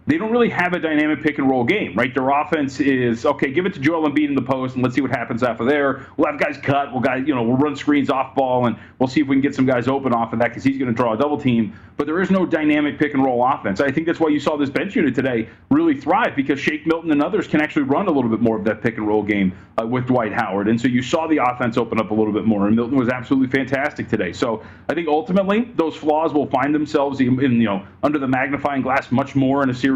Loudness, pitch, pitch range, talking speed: -19 LUFS, 135 Hz, 125-150 Hz, 295 wpm